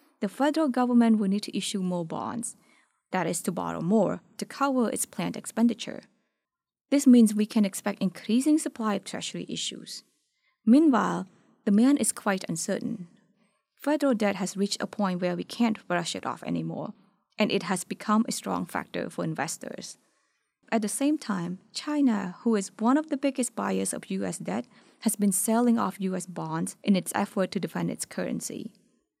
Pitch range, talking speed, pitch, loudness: 195-250 Hz, 175 wpm, 215 Hz, -27 LUFS